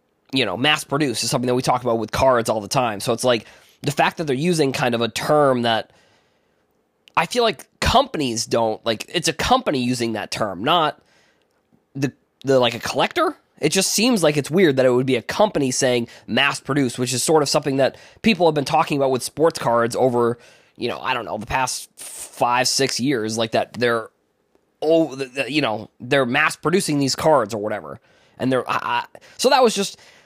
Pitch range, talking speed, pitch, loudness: 120-155 Hz, 210 wpm, 135 Hz, -20 LUFS